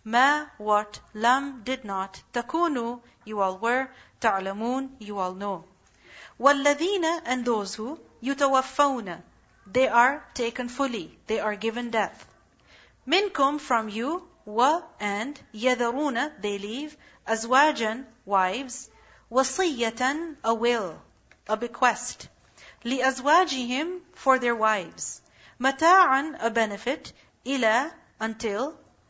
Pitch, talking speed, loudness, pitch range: 250 Hz, 105 wpm, -26 LUFS, 220-275 Hz